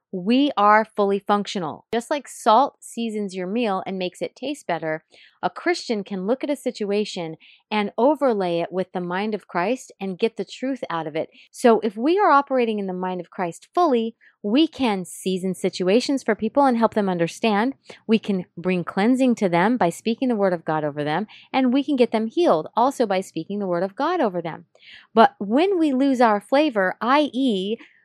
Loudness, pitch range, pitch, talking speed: -22 LUFS, 185-255 Hz, 215 Hz, 200 wpm